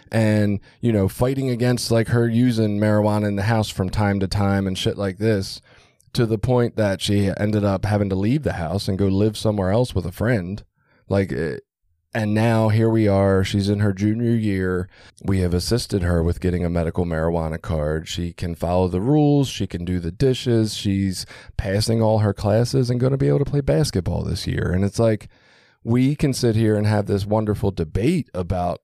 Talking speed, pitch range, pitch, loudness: 205 wpm, 95-115 Hz, 105 Hz, -21 LUFS